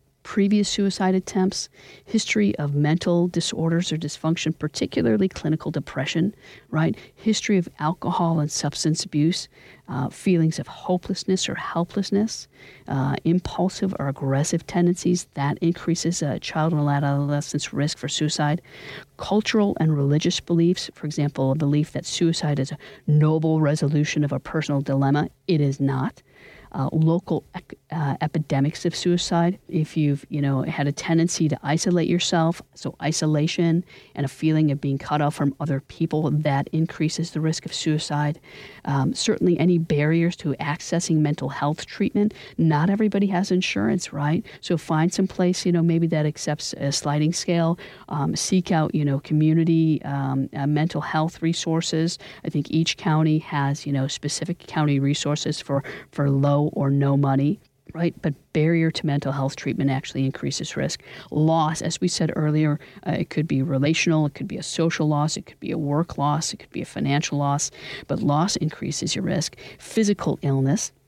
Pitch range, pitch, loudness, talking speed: 145-170 Hz, 155 Hz, -23 LUFS, 165 wpm